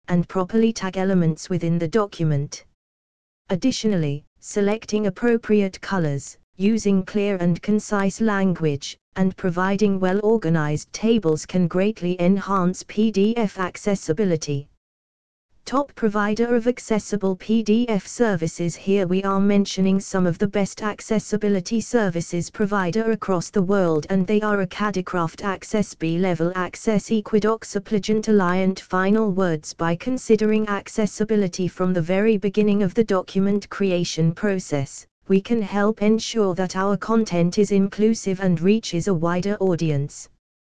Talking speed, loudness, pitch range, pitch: 125 wpm, -22 LUFS, 175-210 Hz, 195 Hz